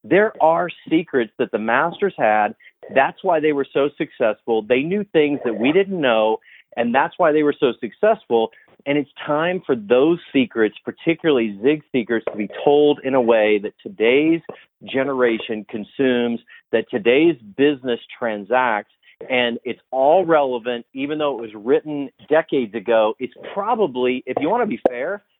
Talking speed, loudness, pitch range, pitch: 165 wpm, -19 LUFS, 115-155 Hz, 135 Hz